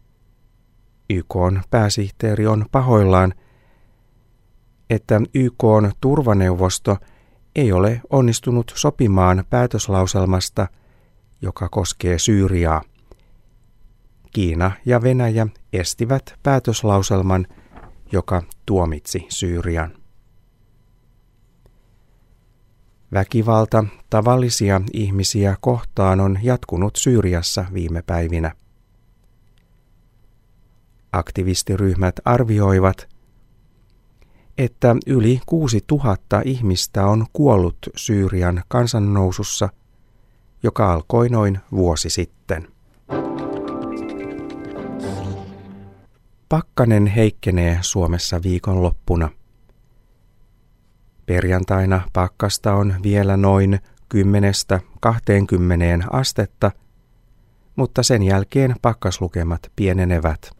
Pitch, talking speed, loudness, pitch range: 100 Hz, 65 wpm, -19 LUFS, 95-115 Hz